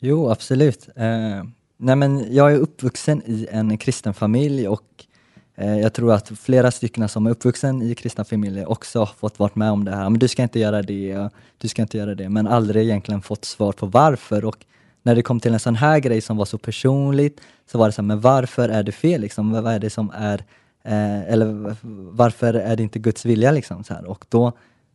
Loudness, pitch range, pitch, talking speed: -20 LUFS, 105-125 Hz, 115 Hz, 225 wpm